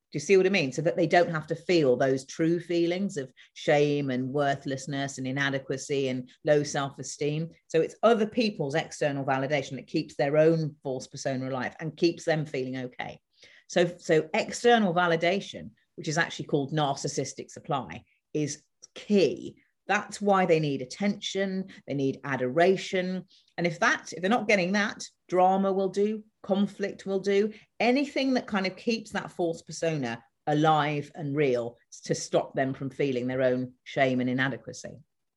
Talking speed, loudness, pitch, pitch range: 165 wpm, -27 LUFS, 160 Hz, 140-190 Hz